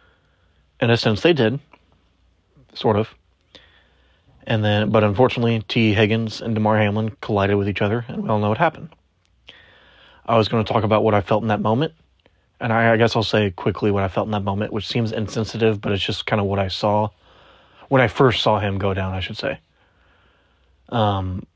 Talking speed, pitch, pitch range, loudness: 200 wpm, 105 Hz, 95-110 Hz, -20 LUFS